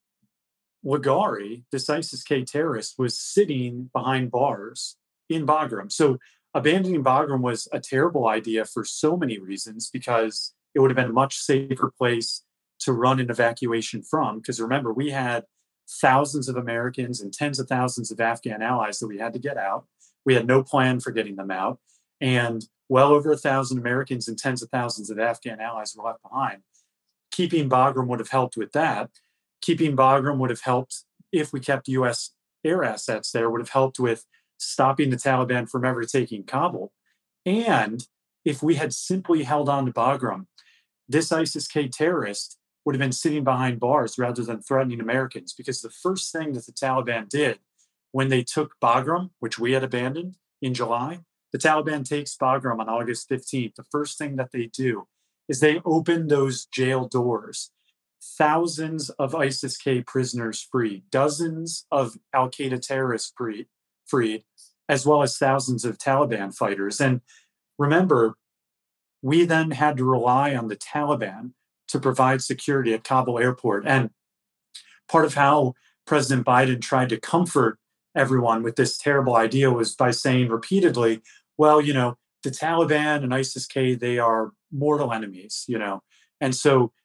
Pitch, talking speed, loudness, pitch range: 130 Hz, 165 wpm, -24 LUFS, 120-145 Hz